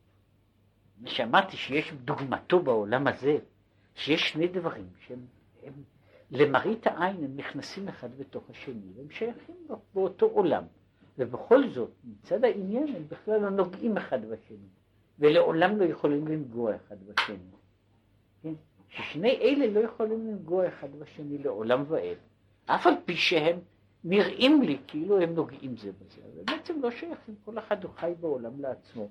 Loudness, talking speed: -28 LUFS, 140 wpm